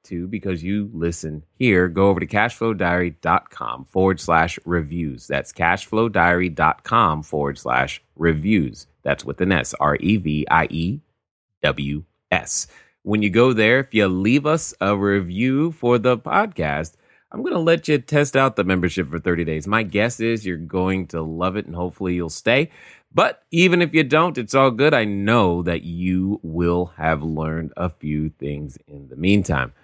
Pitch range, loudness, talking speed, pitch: 80-110 Hz, -20 LUFS, 175 wpm, 90 Hz